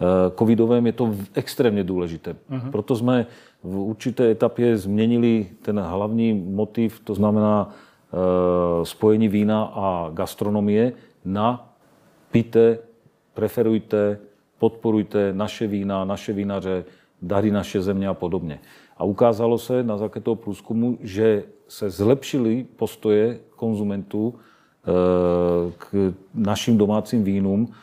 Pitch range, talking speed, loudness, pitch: 95-115 Hz, 105 wpm, -22 LUFS, 105 Hz